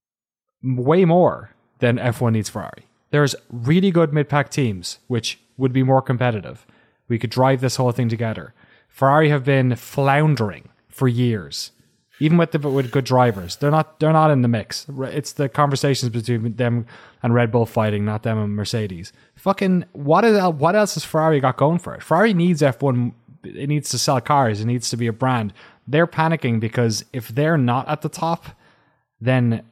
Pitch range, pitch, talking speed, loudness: 120-150 Hz, 130 Hz, 180 wpm, -20 LUFS